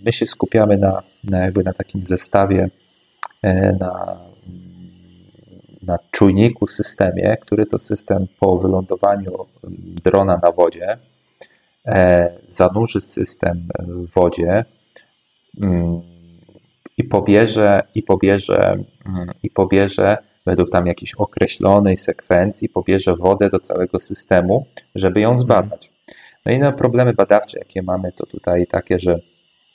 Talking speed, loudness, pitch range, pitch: 120 wpm, -17 LUFS, 90-100 Hz, 95 Hz